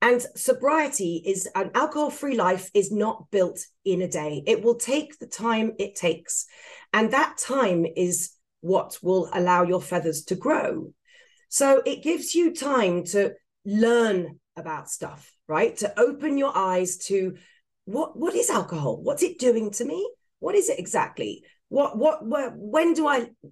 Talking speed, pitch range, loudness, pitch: 165 wpm, 185-295 Hz, -24 LUFS, 230 Hz